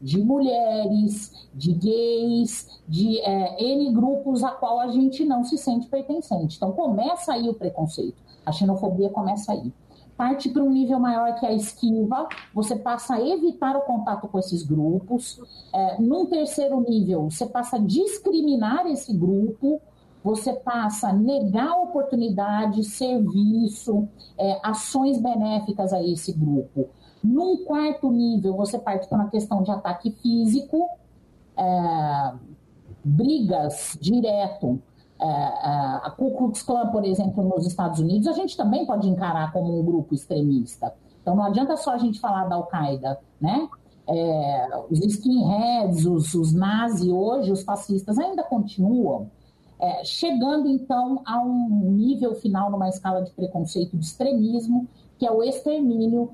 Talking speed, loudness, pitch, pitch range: 145 wpm, -23 LUFS, 215 Hz, 185-250 Hz